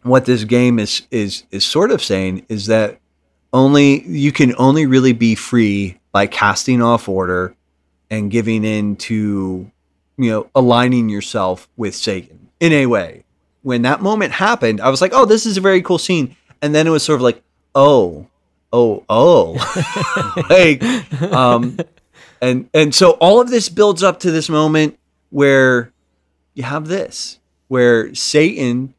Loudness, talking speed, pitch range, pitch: -14 LUFS, 160 wpm, 105-150 Hz, 125 Hz